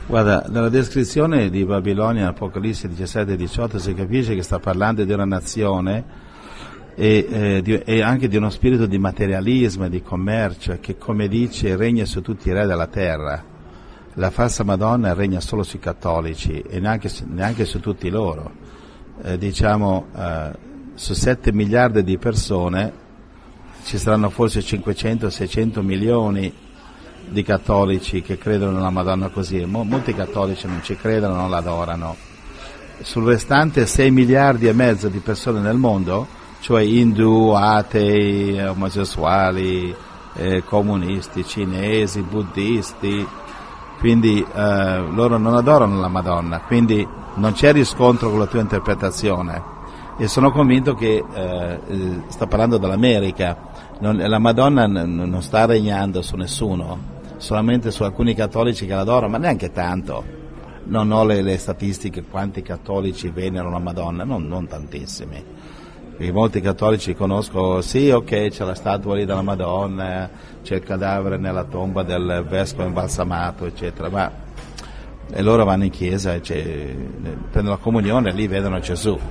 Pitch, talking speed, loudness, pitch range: 100 Hz, 140 wpm, -19 LUFS, 90-110 Hz